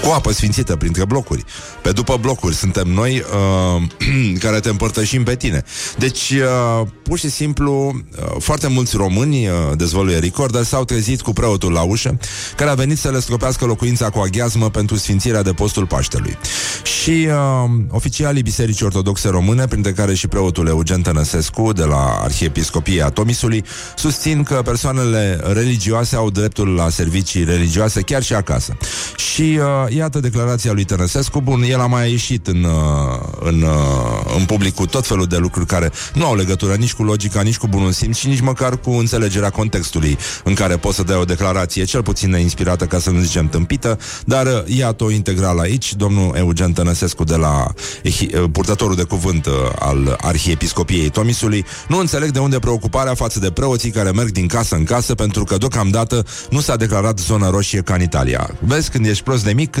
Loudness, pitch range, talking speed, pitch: -16 LUFS, 90-125 Hz, 175 wpm, 105 Hz